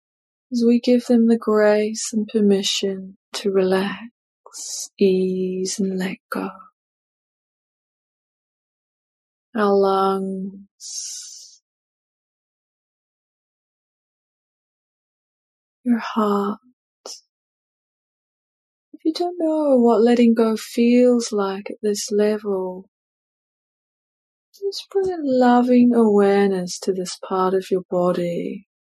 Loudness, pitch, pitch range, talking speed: -20 LUFS, 210 Hz, 195-245 Hz, 85 wpm